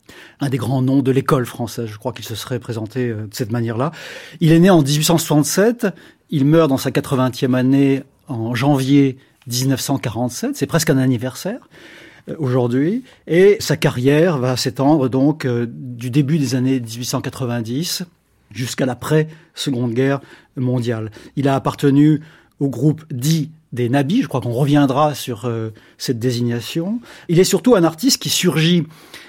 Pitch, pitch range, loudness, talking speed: 135 Hz, 125-155 Hz, -18 LUFS, 150 wpm